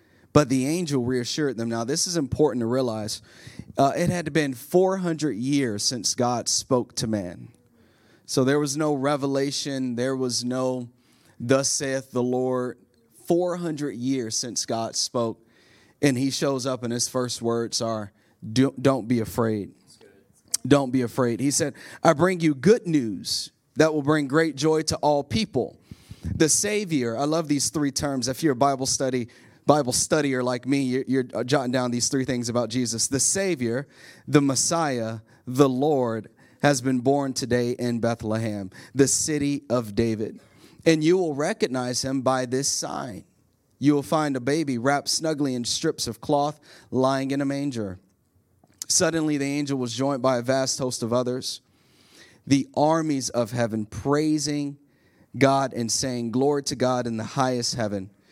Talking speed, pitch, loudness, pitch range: 165 wpm, 130 Hz, -24 LUFS, 120-145 Hz